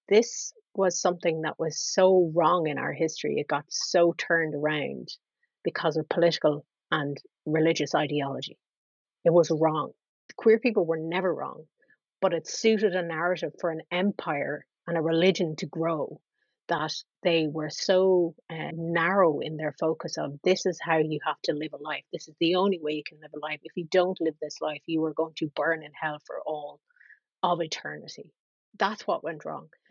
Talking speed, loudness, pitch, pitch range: 185 wpm, -27 LUFS, 165 Hz, 155-180 Hz